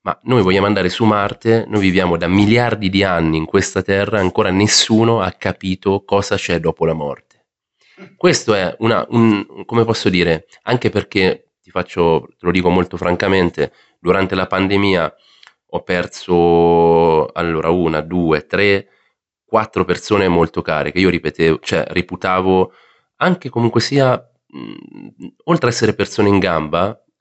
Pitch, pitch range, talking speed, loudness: 95 Hz, 85-110 Hz, 150 wpm, -16 LUFS